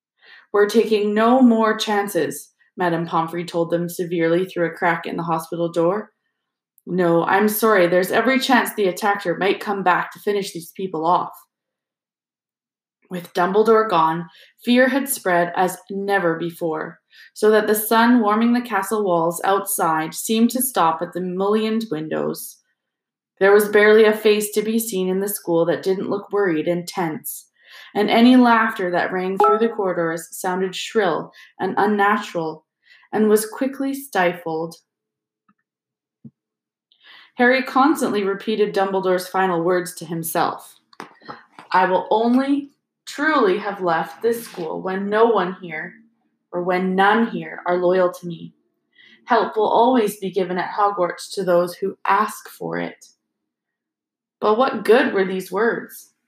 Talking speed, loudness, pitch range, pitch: 145 wpm, -19 LUFS, 175-220 Hz, 195 Hz